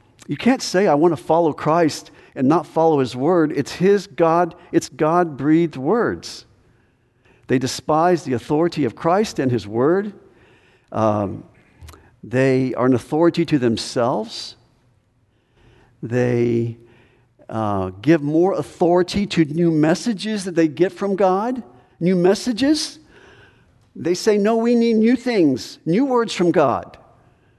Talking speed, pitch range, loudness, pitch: 135 wpm, 125-180 Hz, -19 LUFS, 160 Hz